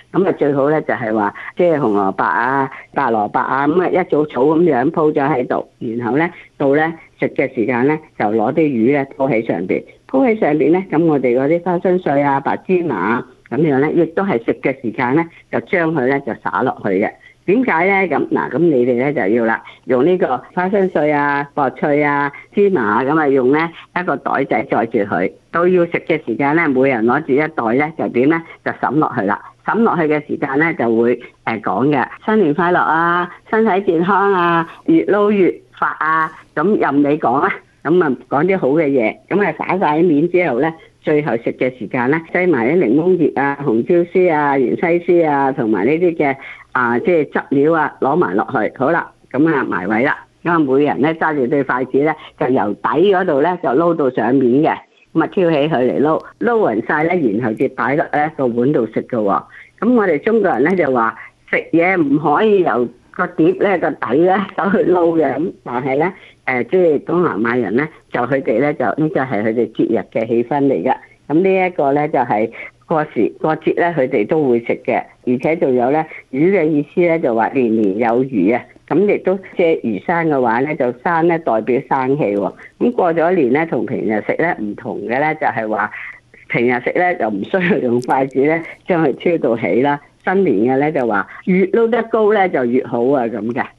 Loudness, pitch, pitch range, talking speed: -16 LUFS, 150 Hz, 130-175 Hz, 280 characters per minute